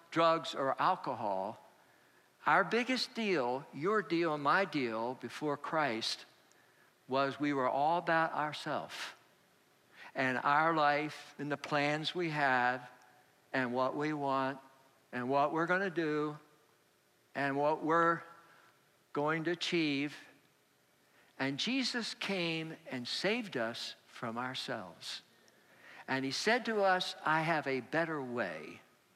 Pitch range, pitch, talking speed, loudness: 130-165 Hz, 145 Hz, 125 wpm, -34 LUFS